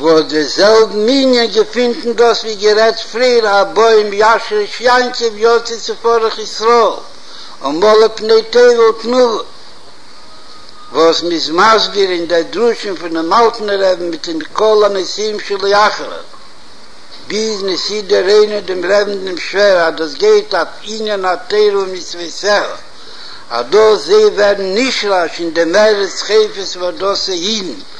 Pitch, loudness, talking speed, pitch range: 210 Hz, -12 LUFS, 150 wpm, 190-230 Hz